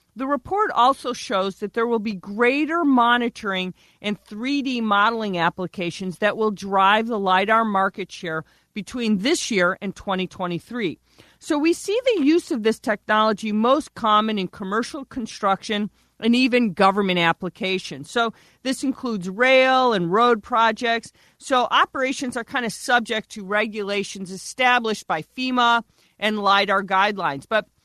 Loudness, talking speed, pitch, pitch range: -21 LUFS, 140 wpm, 220 Hz, 195-245 Hz